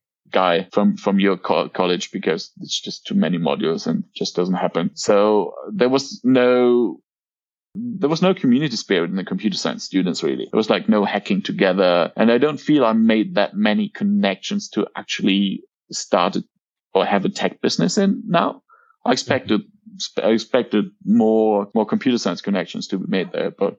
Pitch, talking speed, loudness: 165 Hz, 175 wpm, -19 LUFS